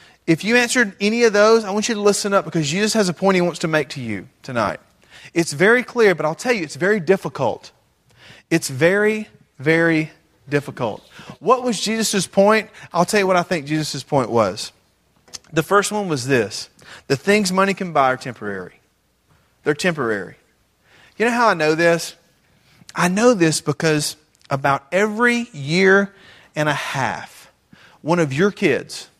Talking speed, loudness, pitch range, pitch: 175 wpm, -19 LUFS, 150-205 Hz, 175 Hz